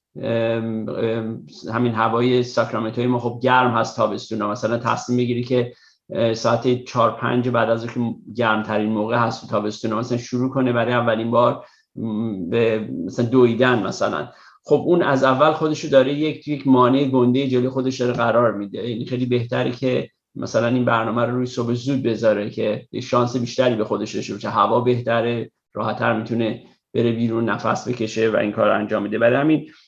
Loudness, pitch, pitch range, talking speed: -20 LUFS, 120 Hz, 115-125 Hz, 165 wpm